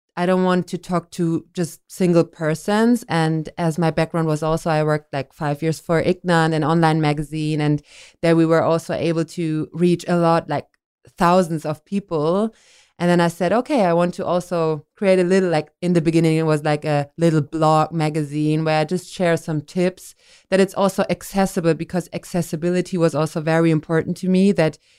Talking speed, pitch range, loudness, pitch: 195 wpm, 155-175 Hz, -20 LUFS, 165 Hz